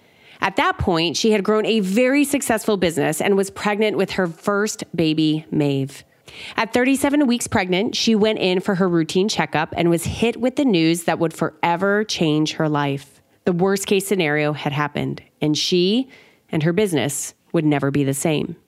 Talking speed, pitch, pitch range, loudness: 185 wpm, 185 Hz, 155-215 Hz, -20 LUFS